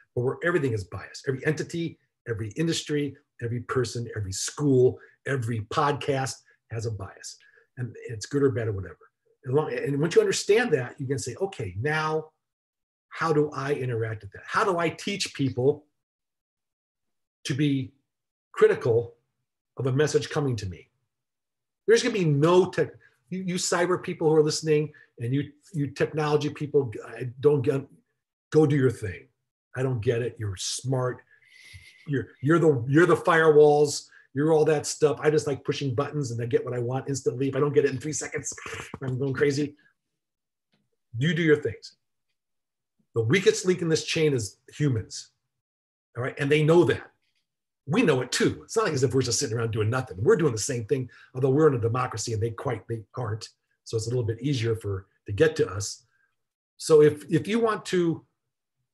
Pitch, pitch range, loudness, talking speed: 140 Hz, 120-155 Hz, -25 LUFS, 190 wpm